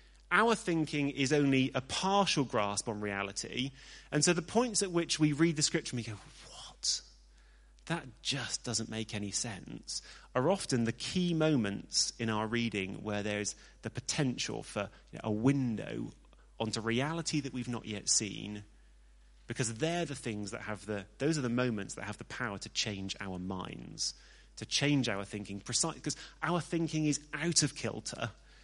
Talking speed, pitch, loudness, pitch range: 175 wpm, 120 Hz, -33 LUFS, 105-150 Hz